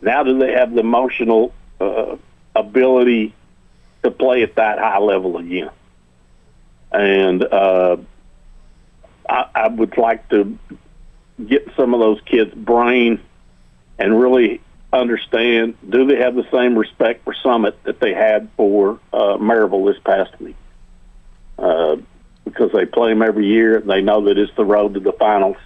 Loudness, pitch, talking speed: -16 LUFS, 105 Hz, 150 wpm